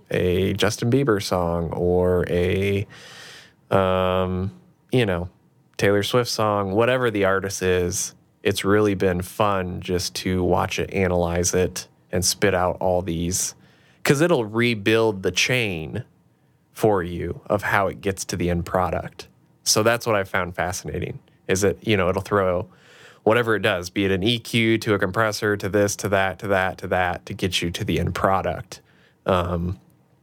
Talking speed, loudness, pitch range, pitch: 165 wpm, -22 LUFS, 90-105 Hz, 95 Hz